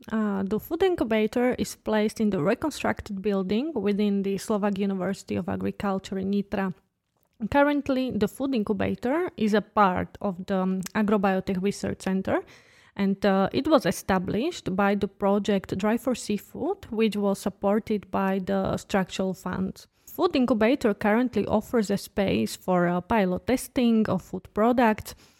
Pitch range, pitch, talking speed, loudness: 195-230 Hz, 205 Hz, 145 wpm, -26 LUFS